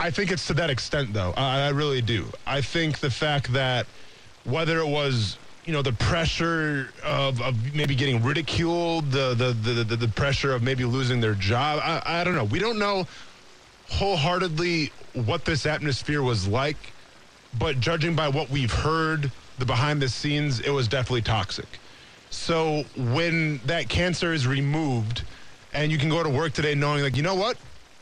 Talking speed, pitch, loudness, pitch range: 180 wpm, 140 Hz, -25 LUFS, 125-160 Hz